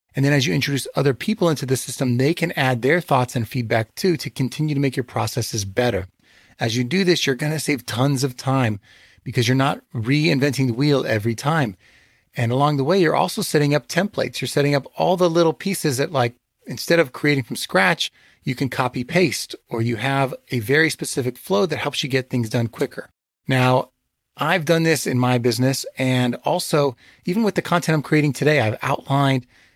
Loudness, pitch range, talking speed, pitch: -20 LUFS, 125-155 Hz, 210 wpm, 135 Hz